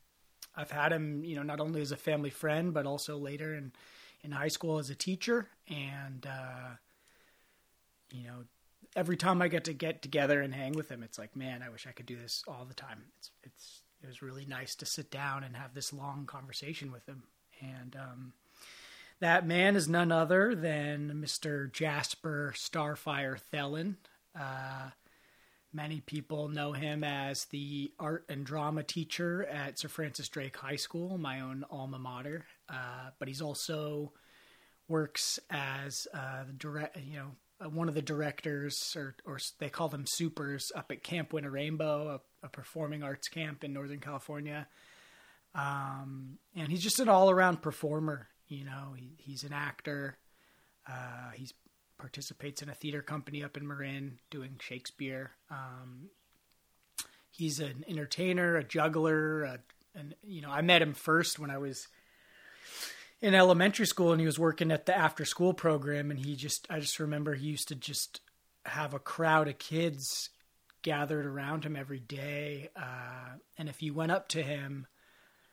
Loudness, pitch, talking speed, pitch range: -34 LUFS, 145 Hz, 170 wpm, 135-155 Hz